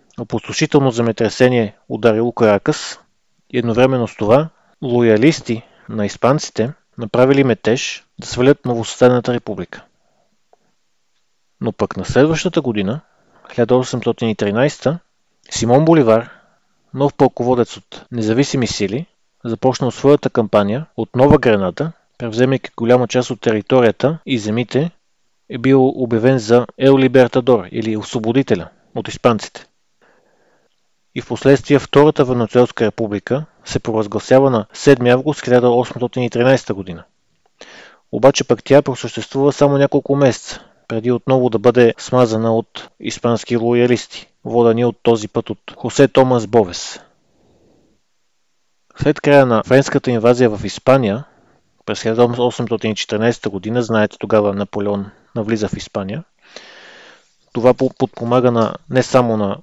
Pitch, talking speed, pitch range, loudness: 120 Hz, 110 wpm, 115-130 Hz, -15 LUFS